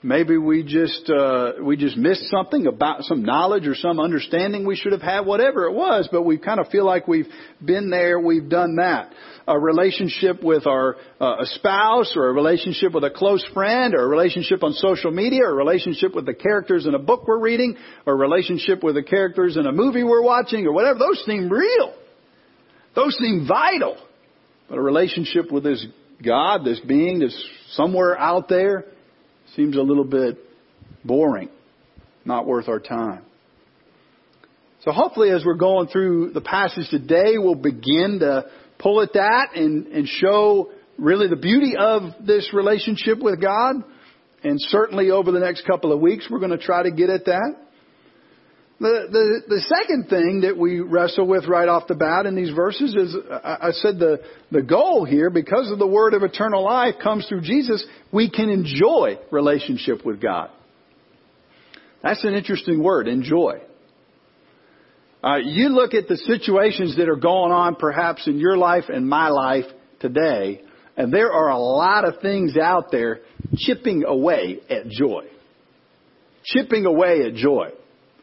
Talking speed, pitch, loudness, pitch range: 175 wpm, 190 Hz, -19 LUFS, 170-225 Hz